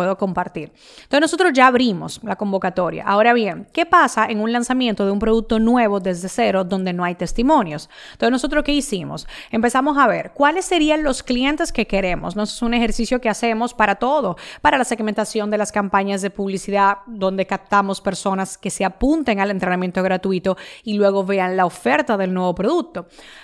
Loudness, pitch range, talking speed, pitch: -19 LUFS, 195-250 Hz, 180 wpm, 215 Hz